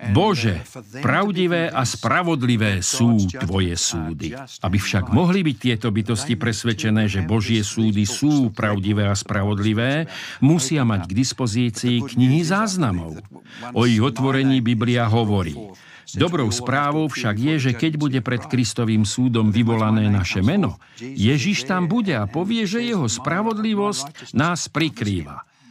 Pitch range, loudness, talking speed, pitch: 110-145 Hz, -20 LUFS, 130 wpm, 120 Hz